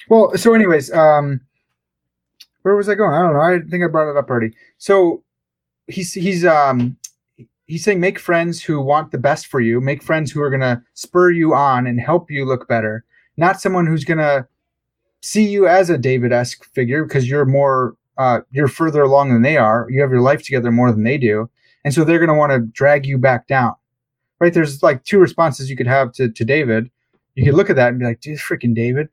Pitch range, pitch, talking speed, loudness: 125-165 Hz, 140 Hz, 220 wpm, -16 LUFS